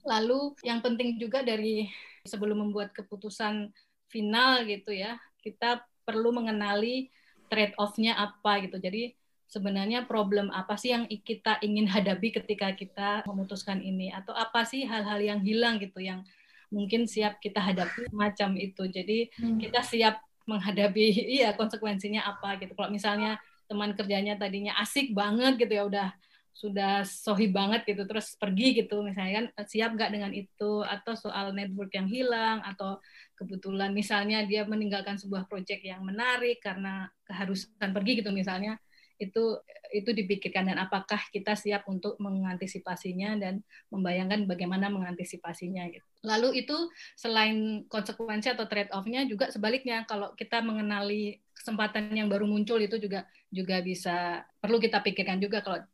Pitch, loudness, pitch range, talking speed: 210 Hz, -30 LUFS, 200-225 Hz, 145 wpm